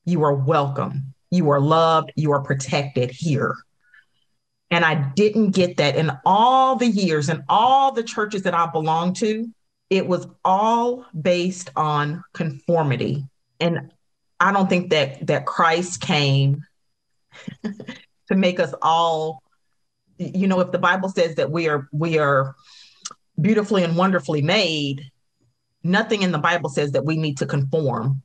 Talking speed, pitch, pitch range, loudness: 150 wpm, 165 Hz, 145-185 Hz, -20 LUFS